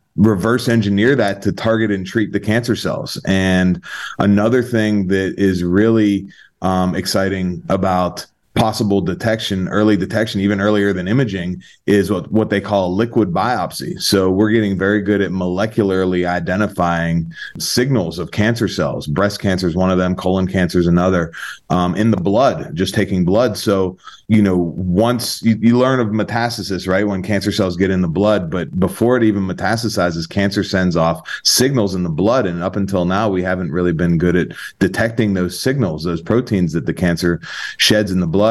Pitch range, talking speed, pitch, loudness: 90-110 Hz, 180 wpm, 100 Hz, -17 LUFS